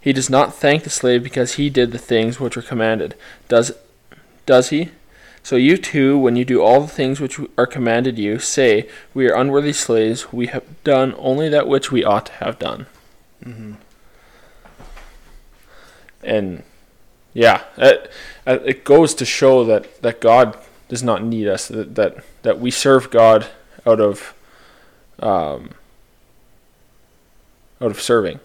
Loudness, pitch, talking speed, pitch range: -16 LUFS, 125 Hz, 155 wpm, 115-140 Hz